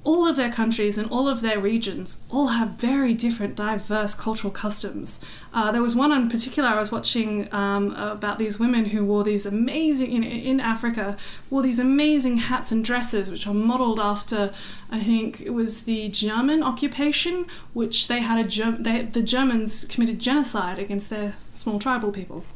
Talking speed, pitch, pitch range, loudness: 180 wpm, 225 Hz, 210-250 Hz, -24 LUFS